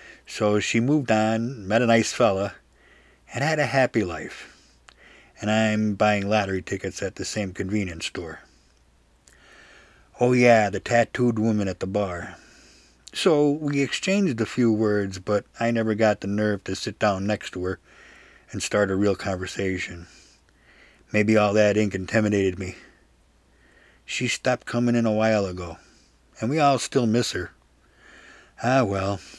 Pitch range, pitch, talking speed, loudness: 95-115 Hz, 105 Hz, 155 wpm, -23 LUFS